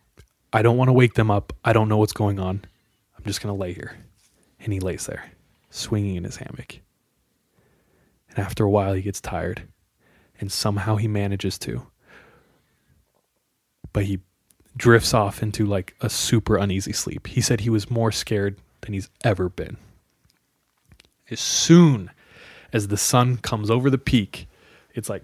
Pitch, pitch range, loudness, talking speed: 105 Hz, 95-115 Hz, -22 LUFS, 165 wpm